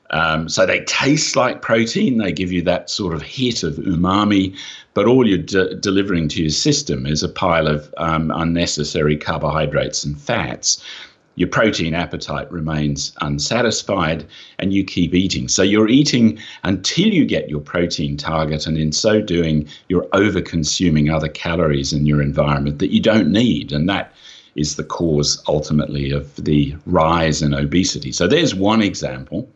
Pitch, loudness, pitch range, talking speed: 80 Hz, -18 LUFS, 75-95 Hz, 160 wpm